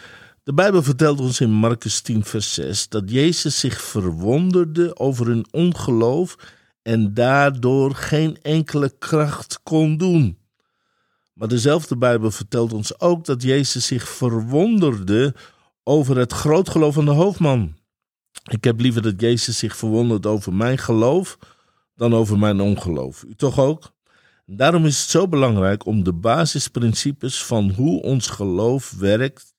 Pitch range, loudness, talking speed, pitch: 110-150 Hz, -19 LUFS, 140 wpm, 125 Hz